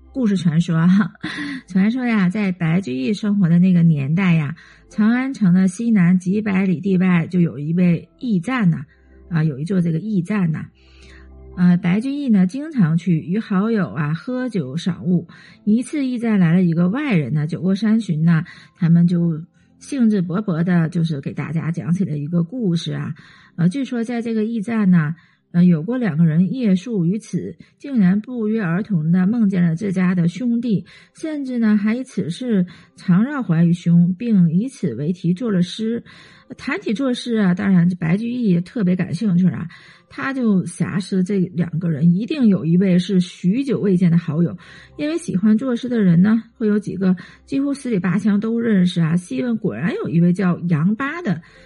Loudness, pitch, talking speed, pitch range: -19 LUFS, 185 Hz, 265 characters per minute, 170-215 Hz